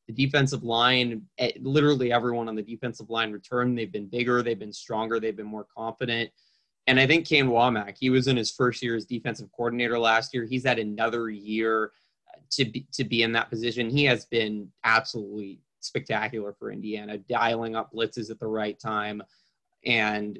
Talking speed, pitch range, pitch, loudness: 180 wpm, 110-125 Hz, 115 Hz, -26 LUFS